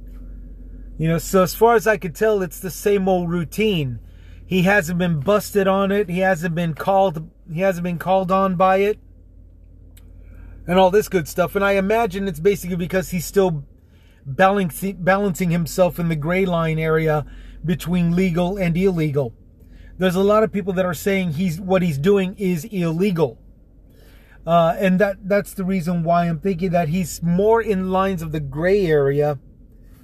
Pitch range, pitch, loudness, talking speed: 160-195 Hz, 180 Hz, -19 LUFS, 175 wpm